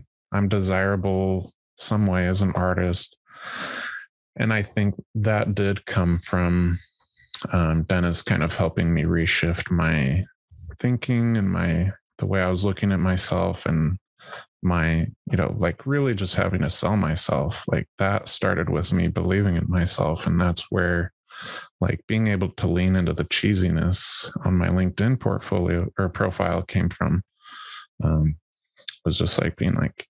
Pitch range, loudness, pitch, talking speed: 85-100 Hz, -23 LUFS, 90 Hz, 155 wpm